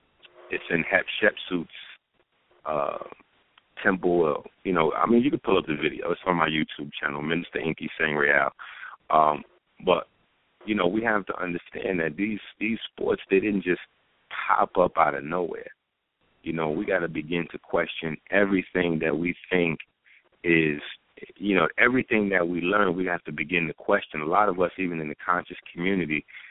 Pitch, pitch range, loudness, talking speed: 85 Hz, 80-95 Hz, -25 LUFS, 175 wpm